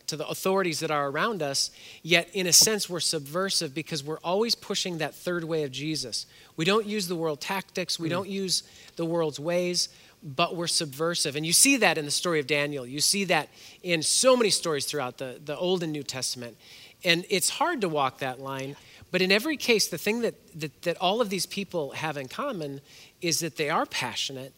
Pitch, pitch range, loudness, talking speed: 165 Hz, 145-185 Hz, -26 LUFS, 215 wpm